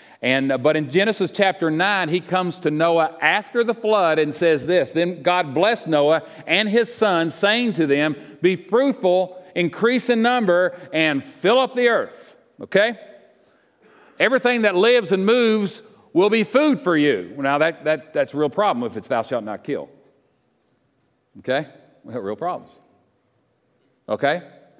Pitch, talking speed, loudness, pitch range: 180 Hz, 160 wpm, -20 LUFS, 160-225 Hz